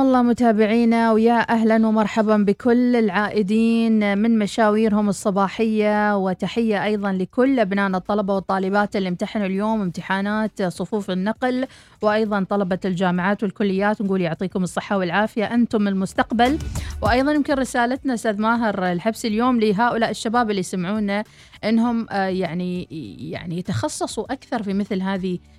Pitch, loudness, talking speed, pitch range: 210 Hz, -20 LUFS, 120 wpm, 195-230 Hz